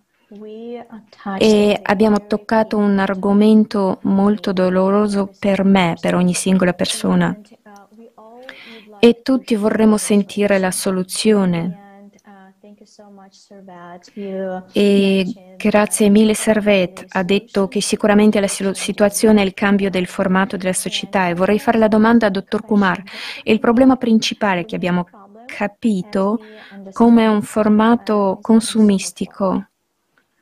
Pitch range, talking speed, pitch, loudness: 195-220 Hz, 110 wpm, 205 Hz, -16 LUFS